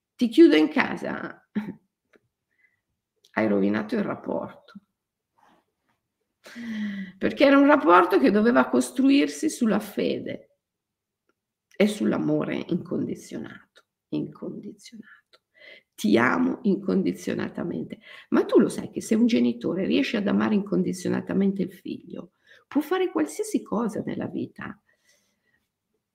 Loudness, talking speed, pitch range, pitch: -24 LUFS, 100 wpm, 185-275 Hz, 210 Hz